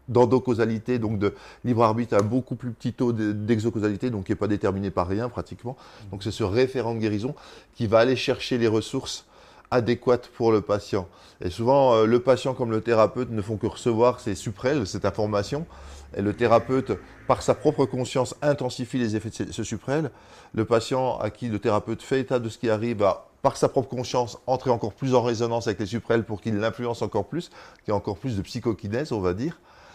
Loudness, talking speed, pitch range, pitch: -25 LUFS, 205 wpm, 110-125 Hz, 115 Hz